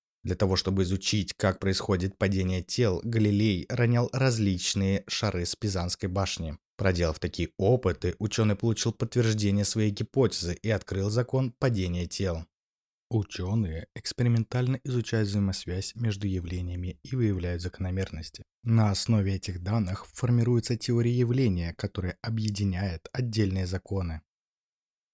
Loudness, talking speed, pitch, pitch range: -28 LUFS, 115 wpm, 100 Hz, 90-115 Hz